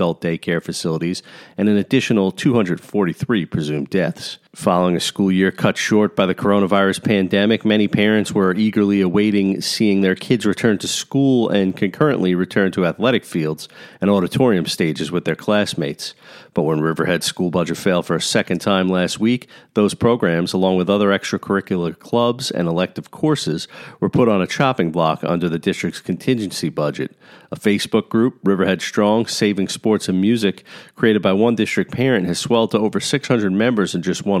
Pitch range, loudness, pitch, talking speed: 90-105 Hz, -18 LUFS, 100 Hz, 170 wpm